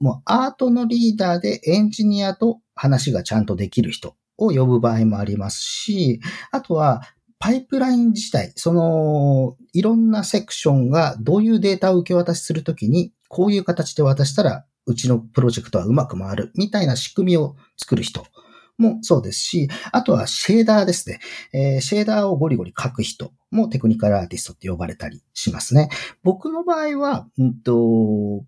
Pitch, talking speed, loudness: 155 Hz, 375 characters per minute, -19 LUFS